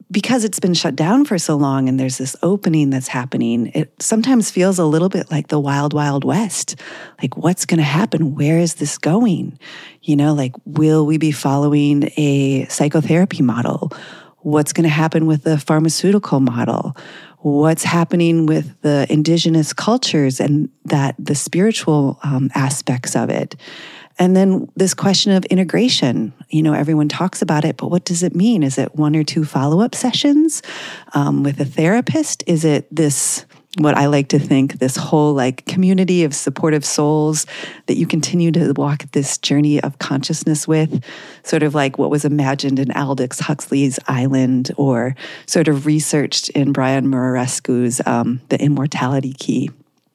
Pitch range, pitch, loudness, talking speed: 140-170 Hz, 150 Hz, -16 LUFS, 170 wpm